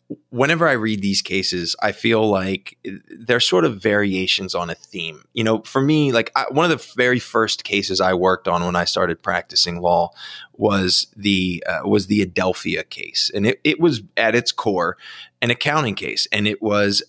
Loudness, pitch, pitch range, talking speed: -19 LUFS, 105 Hz, 95-120 Hz, 195 wpm